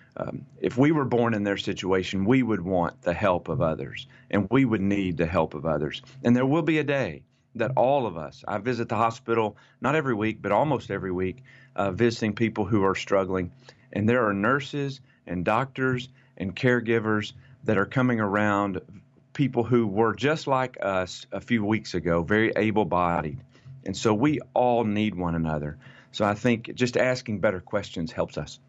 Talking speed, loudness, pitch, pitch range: 190 wpm, -26 LUFS, 110 Hz, 95-125 Hz